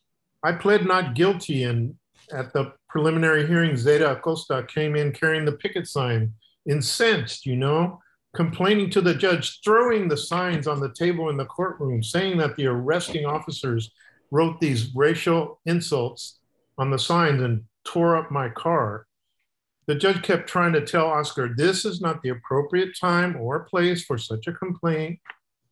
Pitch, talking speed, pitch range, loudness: 155 Hz, 160 wpm, 135-175 Hz, -23 LUFS